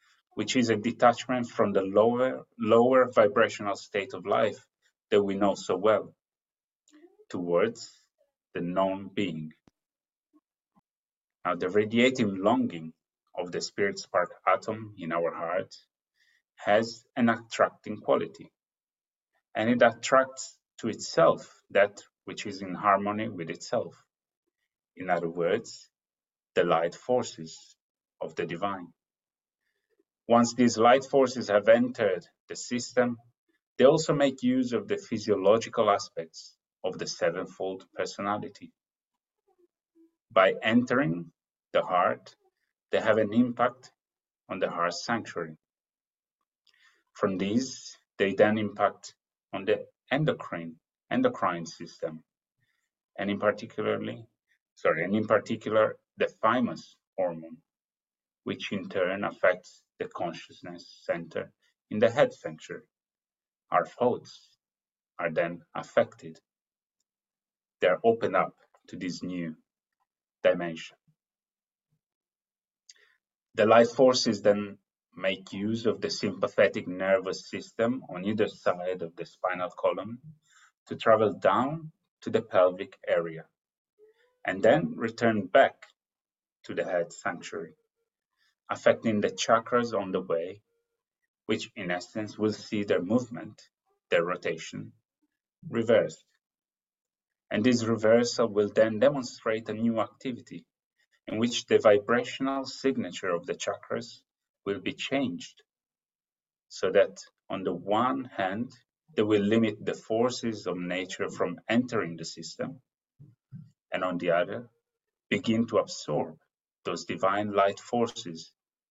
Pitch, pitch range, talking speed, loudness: 115 Hz, 100-150 Hz, 115 wpm, -28 LUFS